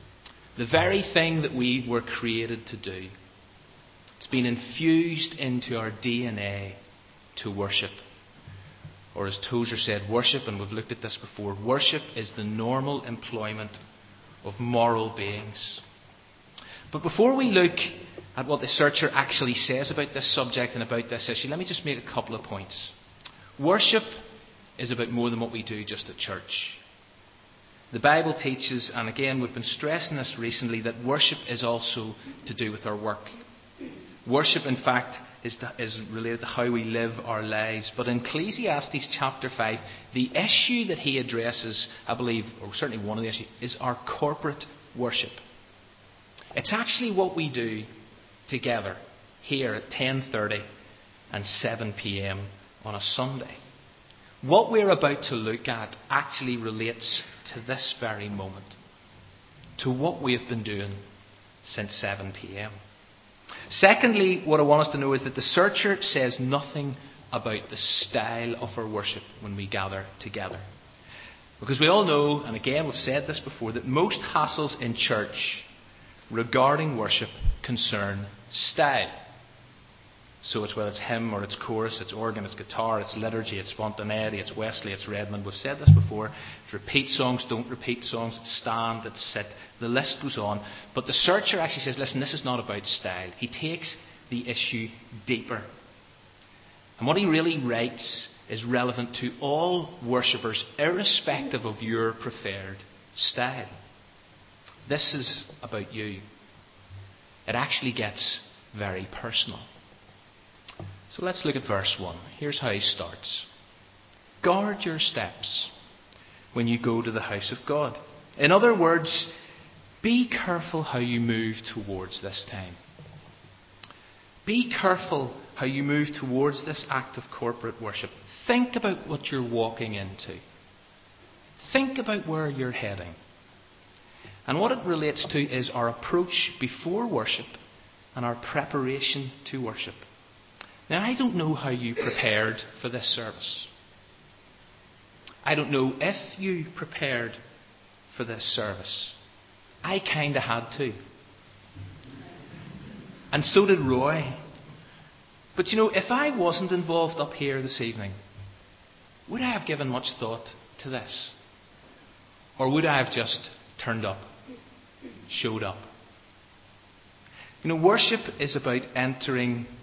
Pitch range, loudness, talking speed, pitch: 105-140 Hz, -27 LUFS, 145 wpm, 120 Hz